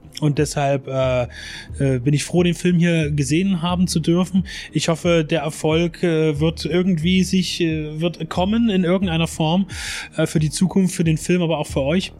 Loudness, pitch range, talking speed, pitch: -20 LUFS, 155-180 Hz, 190 wpm, 165 Hz